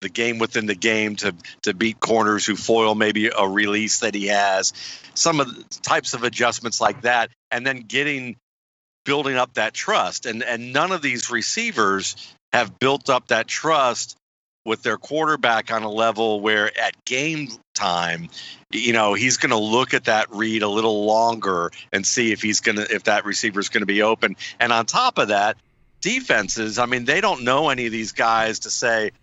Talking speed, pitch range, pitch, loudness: 195 wpm, 105-125 Hz, 115 Hz, -20 LUFS